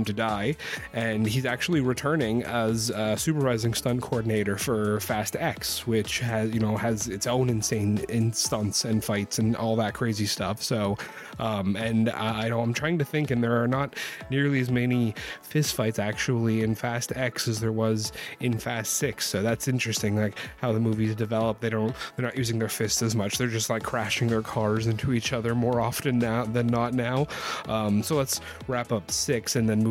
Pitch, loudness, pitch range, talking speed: 115 Hz, -27 LUFS, 110-125 Hz, 200 wpm